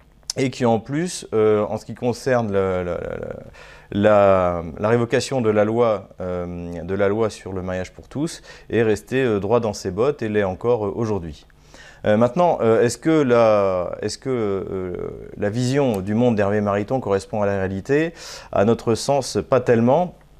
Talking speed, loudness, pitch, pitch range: 180 wpm, -21 LUFS, 105 Hz, 95-125 Hz